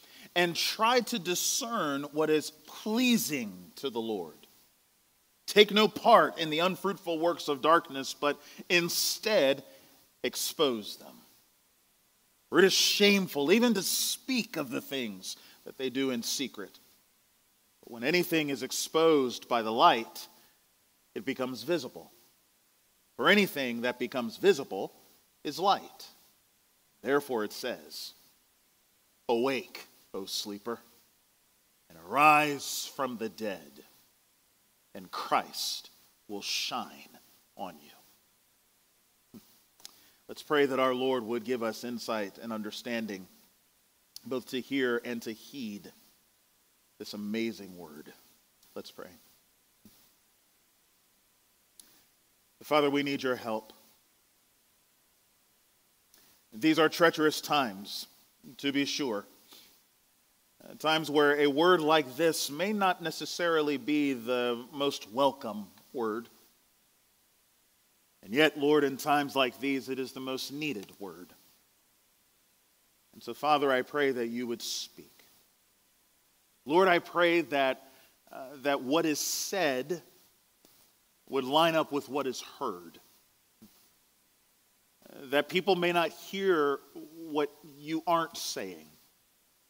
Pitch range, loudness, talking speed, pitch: 125-170 Hz, -29 LUFS, 115 wpm, 145 Hz